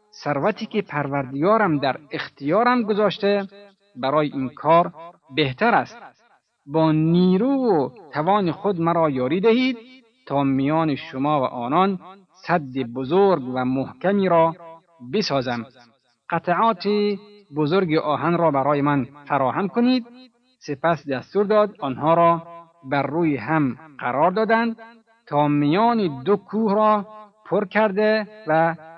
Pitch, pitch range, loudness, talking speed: 170 Hz, 145-205 Hz, -21 LUFS, 115 wpm